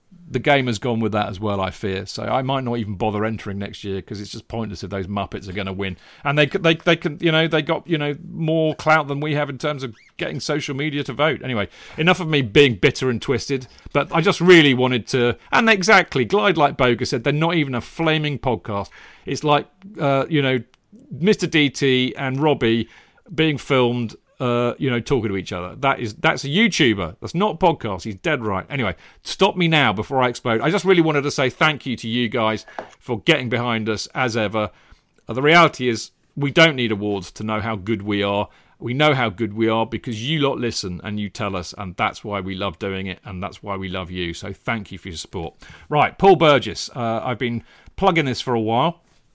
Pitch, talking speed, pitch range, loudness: 125 Hz, 240 wpm, 105-150 Hz, -20 LUFS